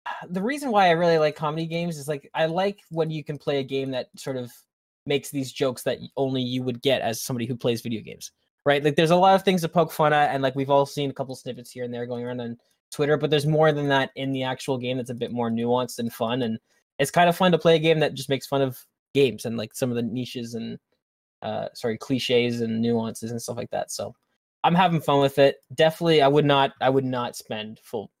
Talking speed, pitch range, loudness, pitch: 260 wpm, 125-155 Hz, -24 LUFS, 135 Hz